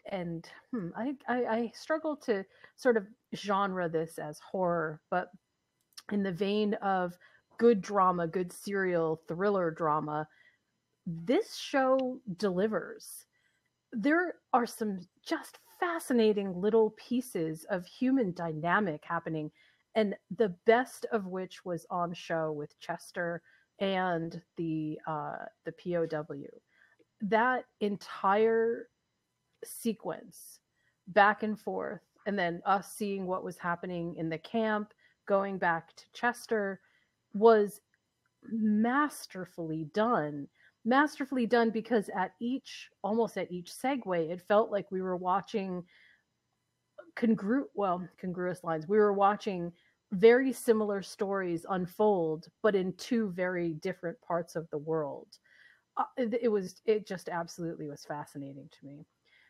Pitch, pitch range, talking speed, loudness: 195 Hz, 170-225 Hz, 120 wpm, -32 LUFS